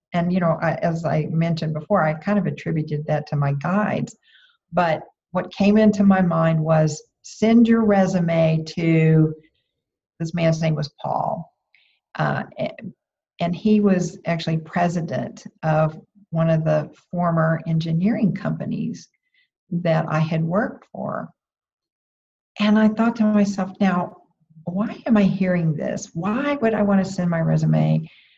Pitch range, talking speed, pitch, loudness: 160-205 Hz, 145 wpm, 175 Hz, -21 LUFS